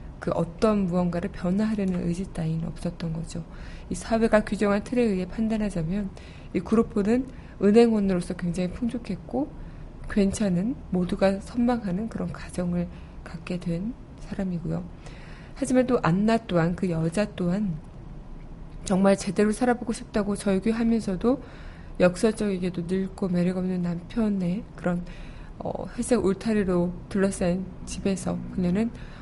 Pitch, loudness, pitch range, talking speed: 195 Hz, -26 LUFS, 175-215 Hz, 295 characters per minute